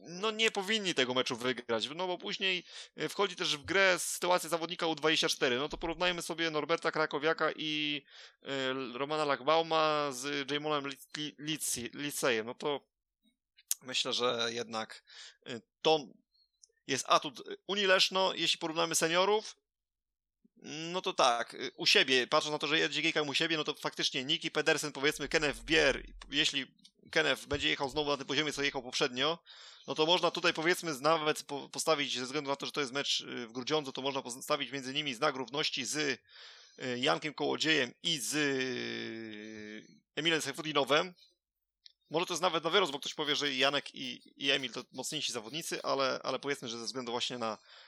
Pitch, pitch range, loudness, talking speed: 150 Hz, 135-165 Hz, -32 LUFS, 165 wpm